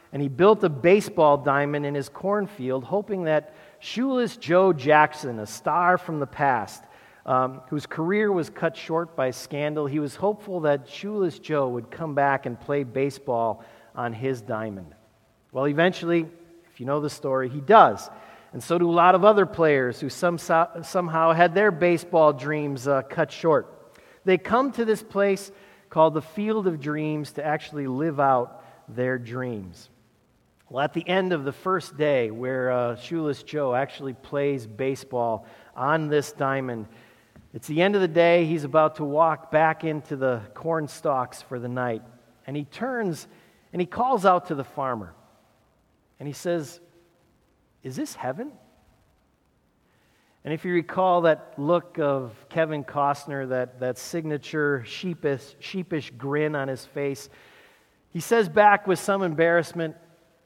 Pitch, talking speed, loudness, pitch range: 150 Hz, 160 wpm, -24 LUFS, 135-175 Hz